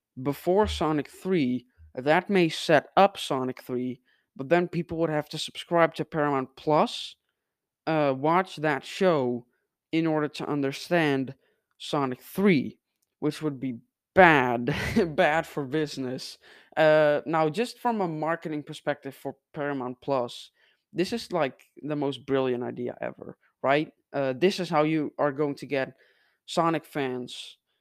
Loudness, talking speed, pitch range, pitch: -27 LUFS, 140 wpm, 135-165 Hz, 150 Hz